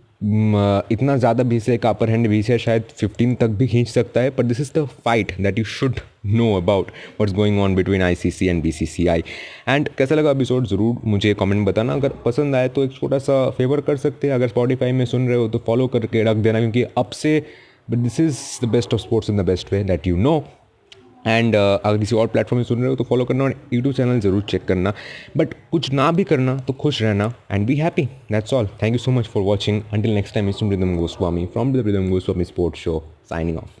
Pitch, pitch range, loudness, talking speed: 115 Hz, 100-125 Hz, -19 LUFS, 240 wpm